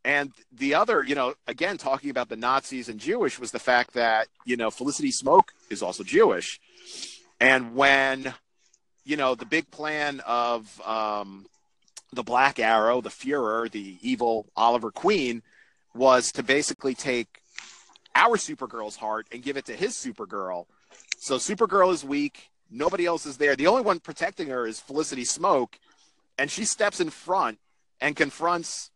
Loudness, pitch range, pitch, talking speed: -25 LUFS, 120-155 Hz, 135 Hz, 160 wpm